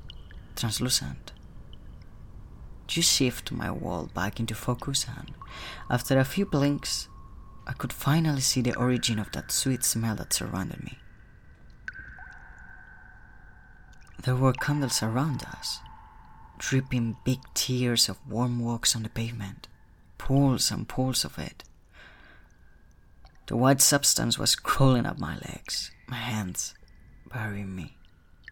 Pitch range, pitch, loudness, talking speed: 100-130 Hz, 120 Hz, -27 LUFS, 120 wpm